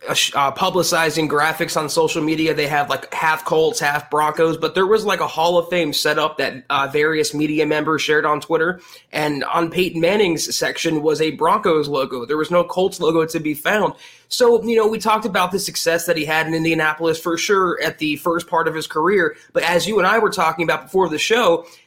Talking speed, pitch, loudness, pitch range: 220 wpm, 160 Hz, -18 LUFS, 155-180 Hz